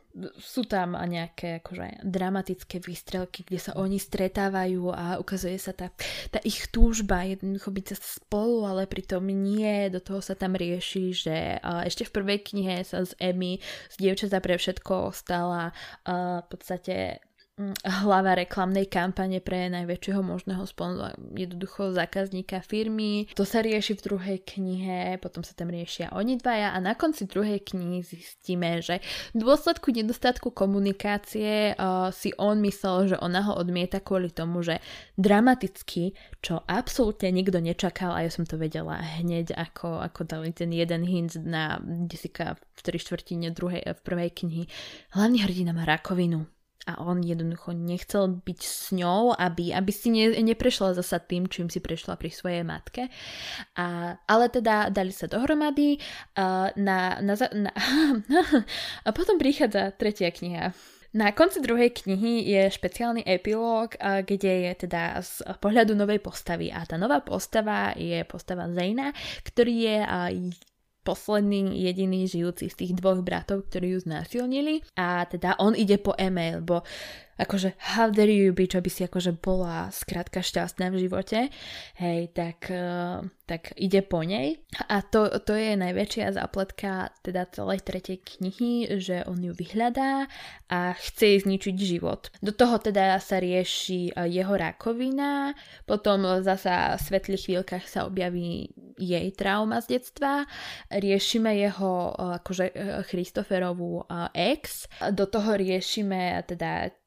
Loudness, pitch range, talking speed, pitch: -27 LUFS, 180-210 Hz, 145 wpm, 190 Hz